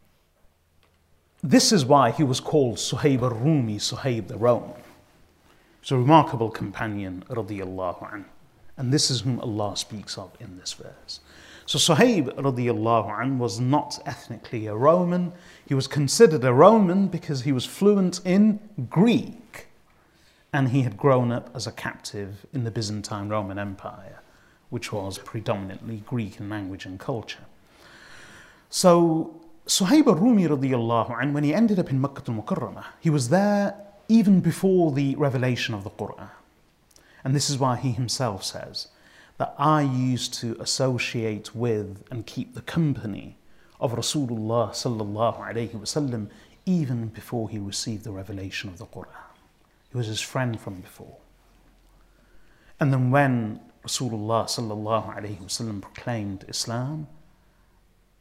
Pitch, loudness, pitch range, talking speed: 120 Hz, -24 LUFS, 105-150 Hz, 145 wpm